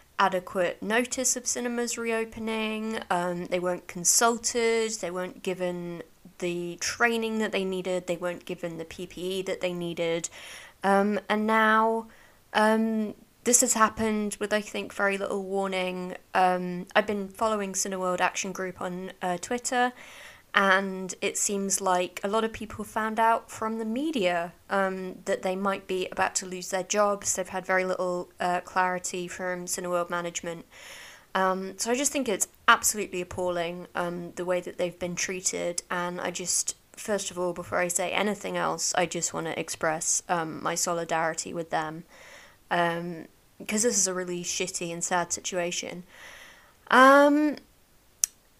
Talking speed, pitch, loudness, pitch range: 155 wpm, 185 Hz, -27 LUFS, 180-220 Hz